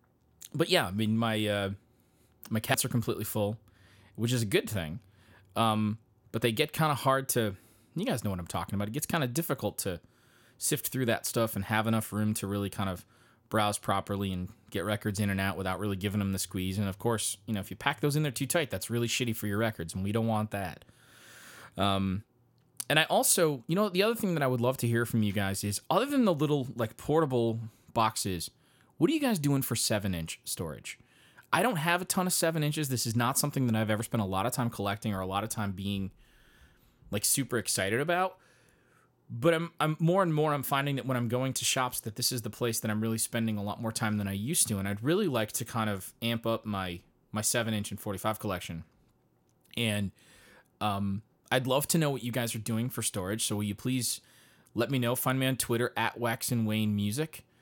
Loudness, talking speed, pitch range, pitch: -30 LUFS, 240 wpm, 105-130 Hz, 115 Hz